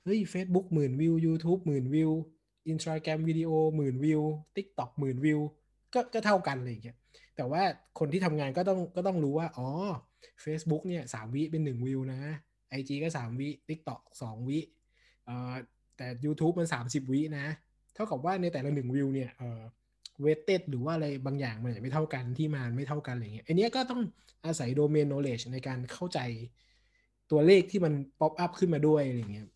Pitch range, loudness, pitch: 130-165 Hz, -32 LUFS, 150 Hz